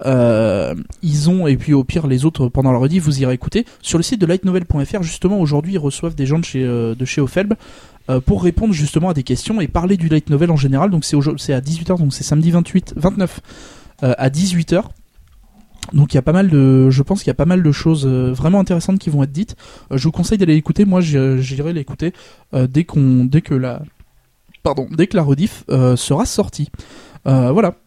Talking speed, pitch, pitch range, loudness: 230 wpm, 155 Hz, 135-180 Hz, -16 LUFS